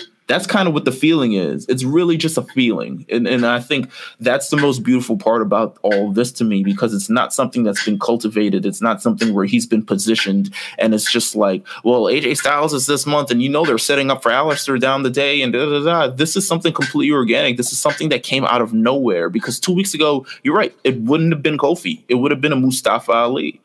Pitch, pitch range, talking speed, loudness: 130 Hz, 115-150 Hz, 245 wpm, -17 LUFS